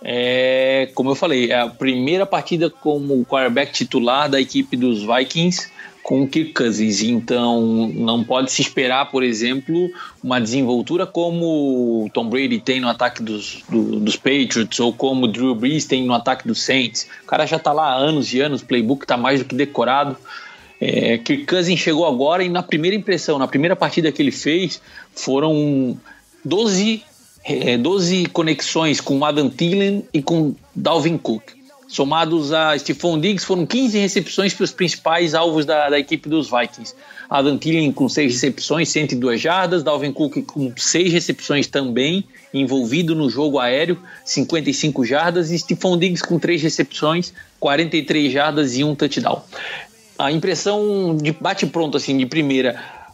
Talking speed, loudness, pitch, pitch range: 165 wpm, -18 LUFS, 150 Hz, 130-170 Hz